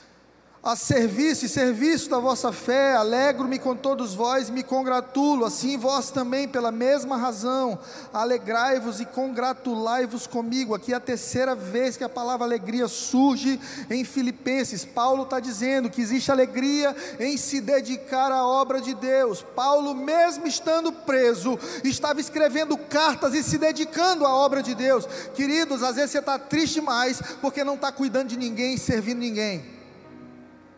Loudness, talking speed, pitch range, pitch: -24 LUFS, 155 wpm, 245-275 Hz, 260 Hz